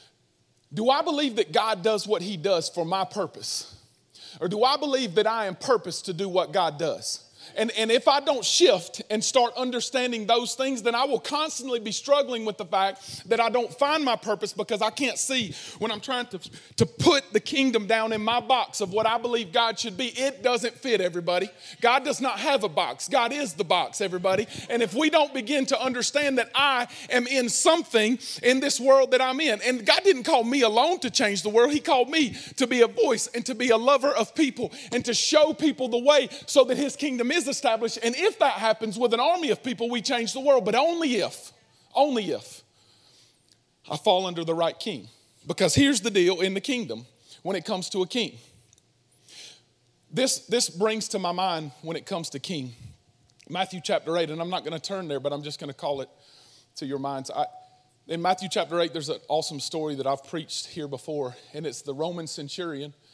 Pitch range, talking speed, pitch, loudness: 185-260 Hz, 220 wpm, 225 Hz, -25 LUFS